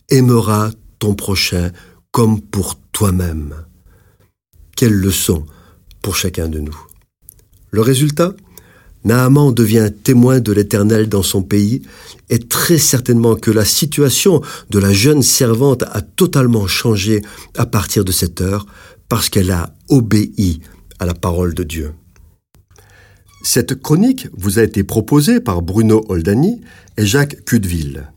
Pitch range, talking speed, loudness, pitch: 90-120 Hz, 130 wpm, -14 LUFS, 105 Hz